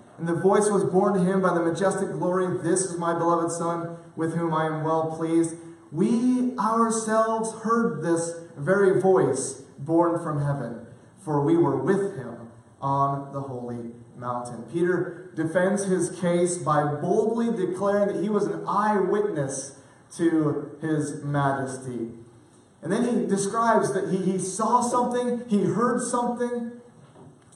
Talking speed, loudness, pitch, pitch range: 145 wpm, -25 LUFS, 175 Hz, 150-200 Hz